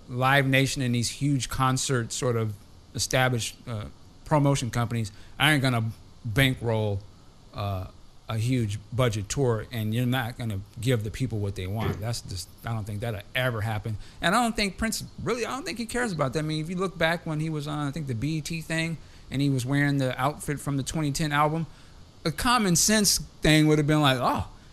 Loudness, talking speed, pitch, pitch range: -26 LUFS, 205 wpm, 130 Hz, 110-155 Hz